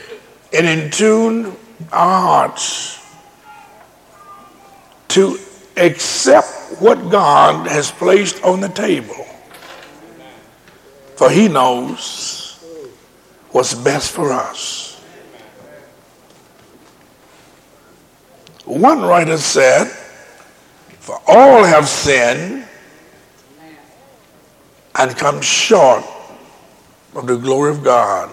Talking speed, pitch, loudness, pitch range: 75 wpm, 190 Hz, -13 LUFS, 160-225 Hz